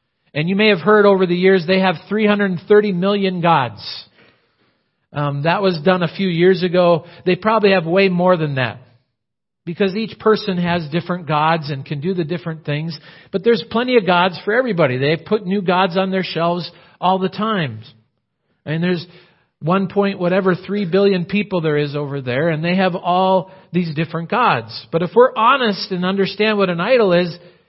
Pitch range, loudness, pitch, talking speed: 165-195 Hz, -17 LUFS, 180 Hz, 195 wpm